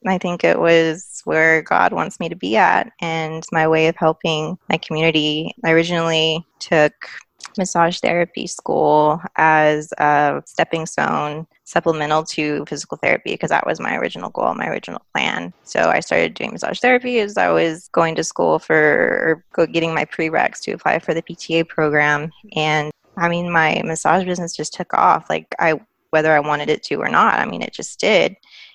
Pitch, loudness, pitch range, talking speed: 160 Hz, -18 LUFS, 155-170 Hz, 180 wpm